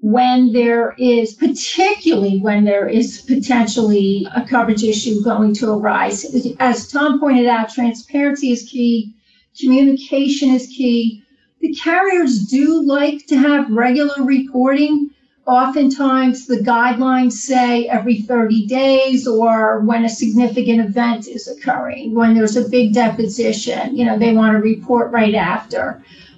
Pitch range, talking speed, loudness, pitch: 230-270 Hz, 135 wpm, -15 LUFS, 245 Hz